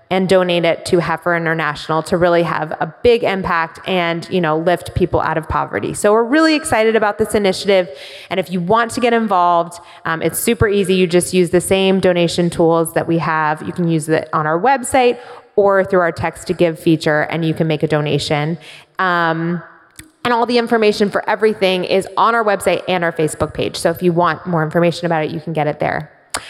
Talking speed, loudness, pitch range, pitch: 215 wpm, -16 LUFS, 165-190 Hz, 175 Hz